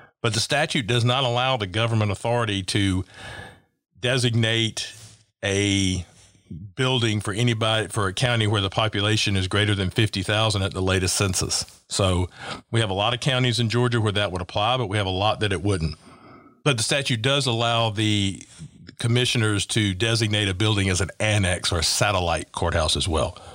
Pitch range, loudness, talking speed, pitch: 95-115 Hz, -22 LUFS, 180 wpm, 105 Hz